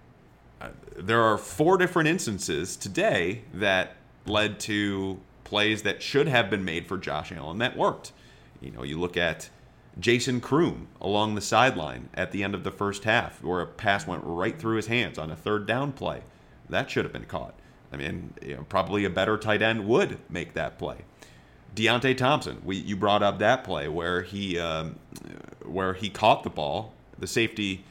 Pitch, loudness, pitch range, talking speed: 105 Hz, -27 LUFS, 90-110 Hz, 185 wpm